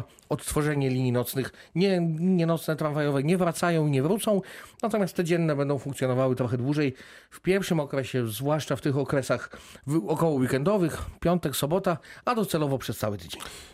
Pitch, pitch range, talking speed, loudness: 150 Hz, 135-175 Hz, 155 wpm, -27 LUFS